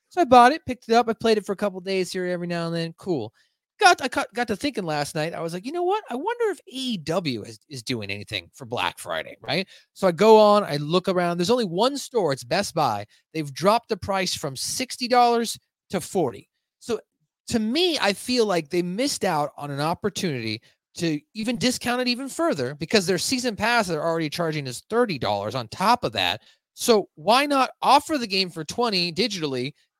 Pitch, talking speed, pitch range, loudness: 200 Hz, 220 wpm, 160-245 Hz, -23 LUFS